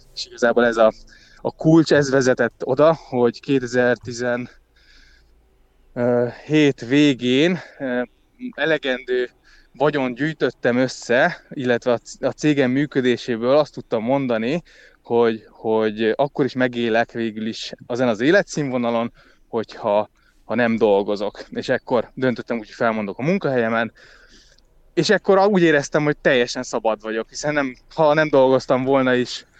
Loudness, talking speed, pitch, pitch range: -20 LUFS, 120 wpm, 125 Hz, 115-145 Hz